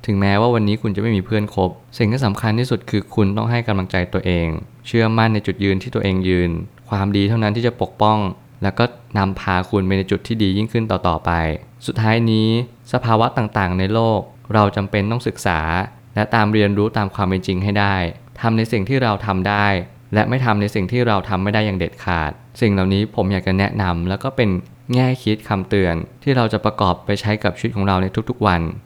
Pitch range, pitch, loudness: 95-115 Hz, 105 Hz, -19 LUFS